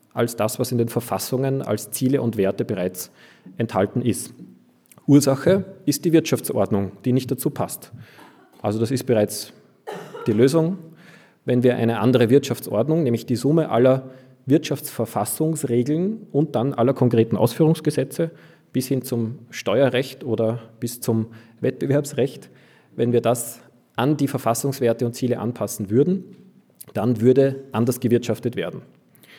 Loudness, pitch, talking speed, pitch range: -22 LUFS, 125 Hz, 135 wpm, 115-140 Hz